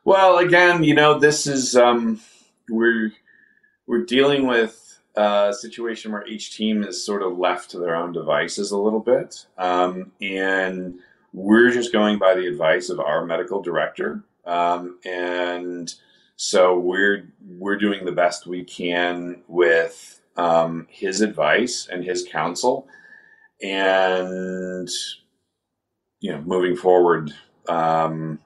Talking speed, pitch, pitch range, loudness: 130 wpm, 95 Hz, 90-115 Hz, -20 LUFS